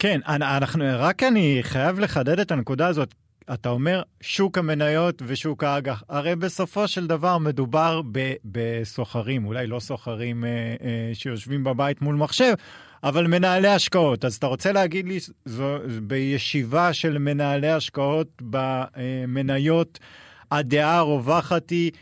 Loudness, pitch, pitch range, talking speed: -23 LUFS, 145 Hz, 130-170 Hz, 125 wpm